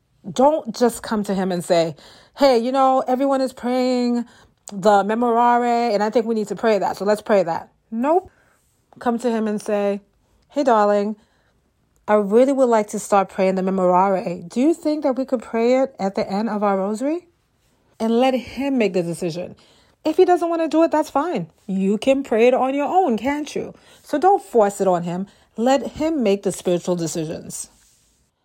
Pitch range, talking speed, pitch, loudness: 200-265 Hz, 200 wpm, 225 Hz, -20 LUFS